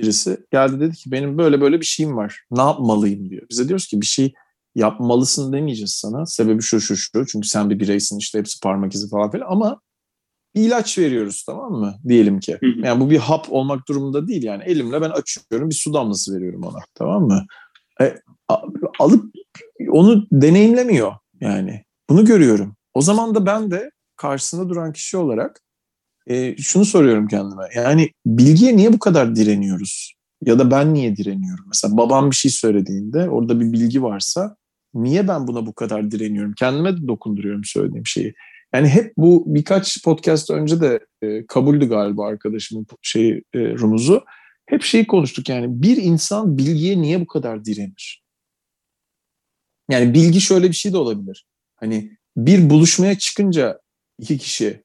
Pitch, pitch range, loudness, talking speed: 135 Hz, 110-175 Hz, -17 LUFS, 165 wpm